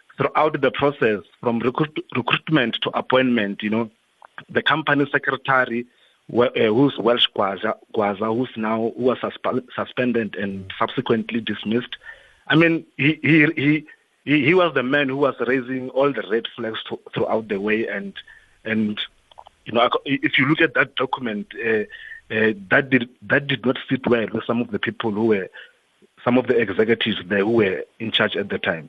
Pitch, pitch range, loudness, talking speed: 130 Hz, 115-145 Hz, -21 LUFS, 175 wpm